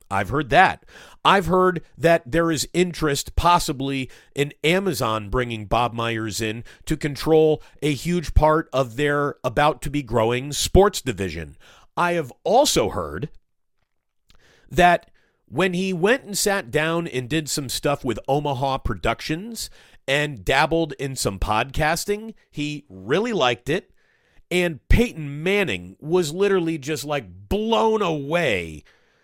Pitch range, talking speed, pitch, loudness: 125-175 Hz, 135 wpm, 150 Hz, -22 LUFS